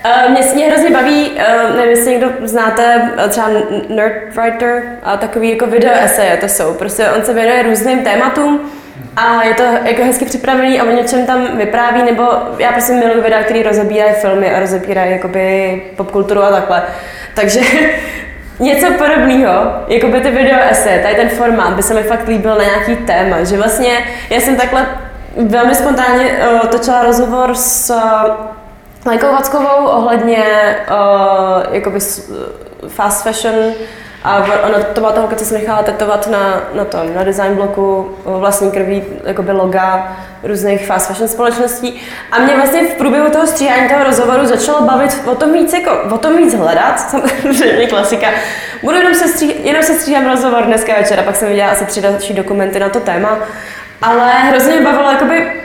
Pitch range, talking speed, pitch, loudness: 205-255 Hz, 170 wpm, 230 Hz, -11 LUFS